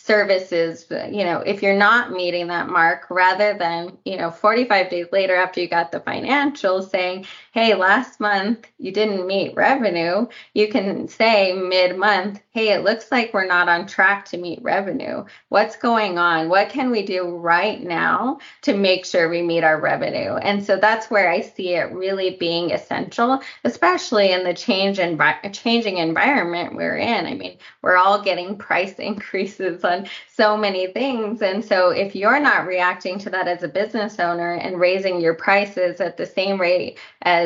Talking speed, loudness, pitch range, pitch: 180 wpm, -19 LUFS, 180-210 Hz, 195 Hz